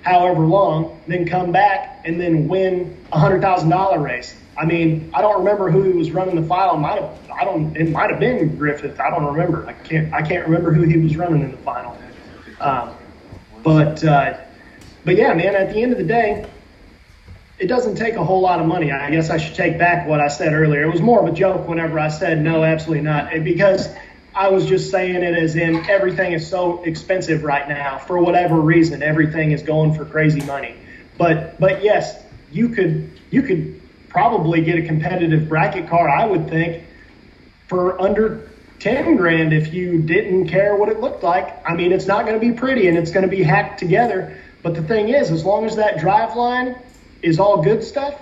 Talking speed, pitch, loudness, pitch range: 210 wpm, 170 Hz, -17 LUFS, 155-190 Hz